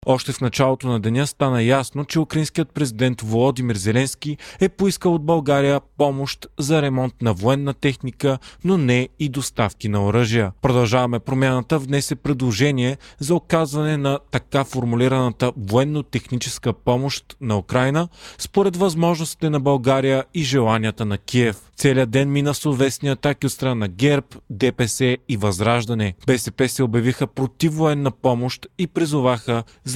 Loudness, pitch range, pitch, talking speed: -20 LUFS, 125-145 Hz, 135 Hz, 145 wpm